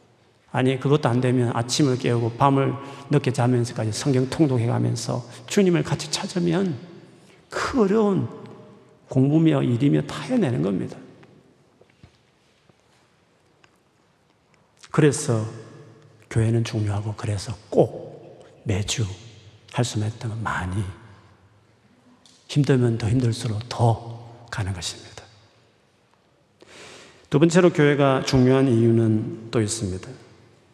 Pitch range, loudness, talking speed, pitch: 110-140 Hz, -22 LUFS, 220 characters per minute, 120 Hz